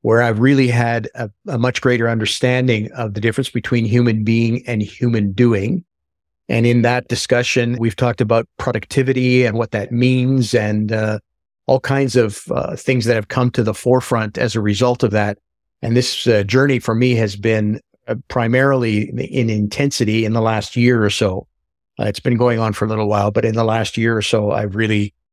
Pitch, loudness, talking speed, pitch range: 115 Hz, -17 LUFS, 200 wpm, 105-125 Hz